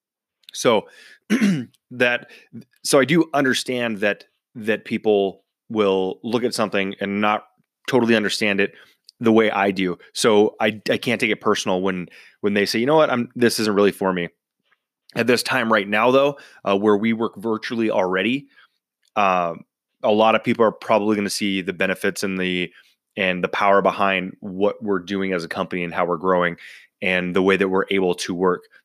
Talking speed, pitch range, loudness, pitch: 185 wpm, 95-115 Hz, -20 LUFS, 100 Hz